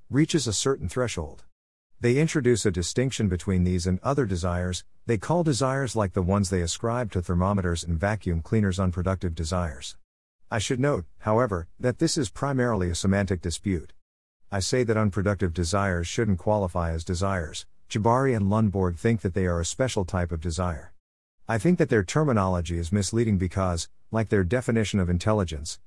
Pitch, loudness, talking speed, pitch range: 100 Hz, -26 LUFS, 170 wpm, 90-115 Hz